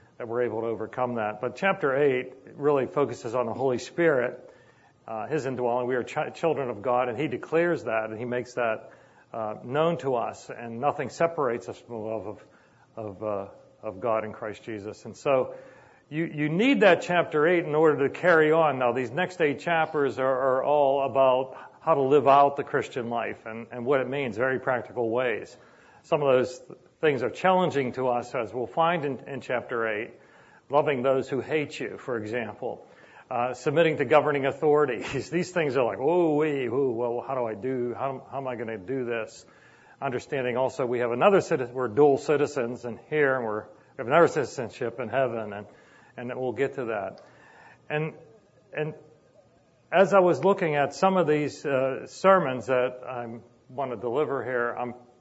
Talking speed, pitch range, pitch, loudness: 190 wpm, 120-150 Hz, 130 Hz, -26 LUFS